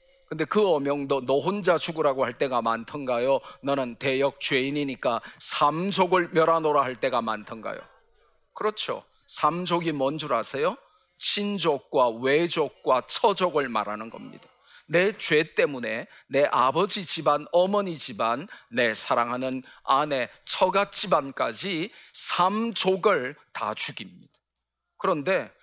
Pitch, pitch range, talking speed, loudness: 150 Hz, 135-185 Hz, 255 characters per minute, -25 LUFS